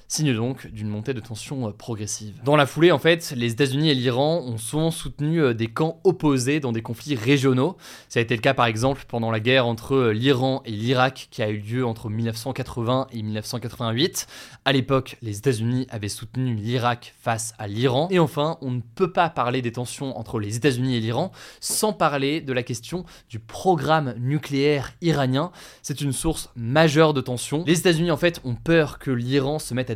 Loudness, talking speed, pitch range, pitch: -23 LUFS, 195 wpm, 120-150 Hz, 130 Hz